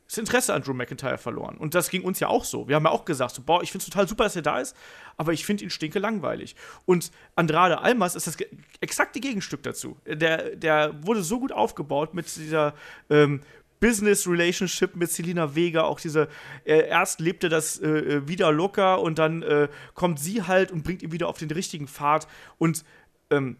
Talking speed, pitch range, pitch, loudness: 205 wpm, 155-185 Hz, 165 Hz, -25 LUFS